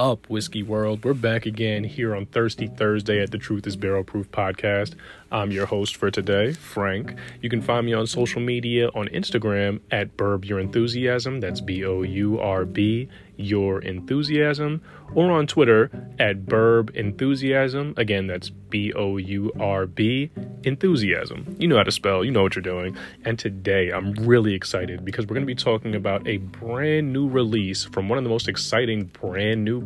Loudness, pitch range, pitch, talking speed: -23 LUFS, 100-120 Hz, 105 Hz, 170 wpm